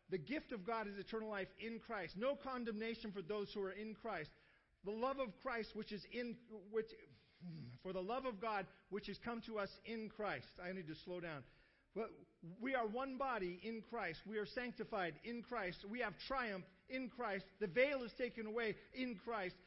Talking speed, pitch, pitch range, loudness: 200 wpm, 215 Hz, 190-235 Hz, -46 LUFS